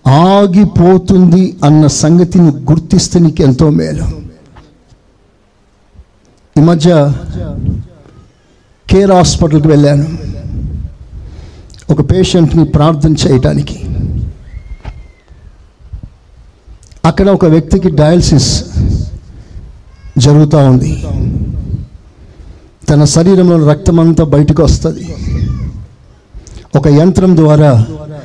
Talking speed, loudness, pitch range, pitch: 65 wpm, -9 LUFS, 100-165 Hz, 150 Hz